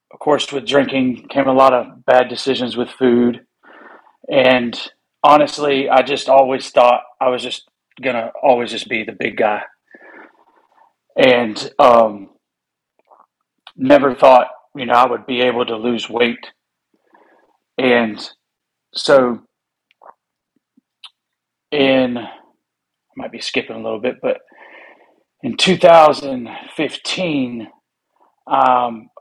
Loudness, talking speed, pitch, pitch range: -15 LUFS, 110 wpm, 125 Hz, 120-135 Hz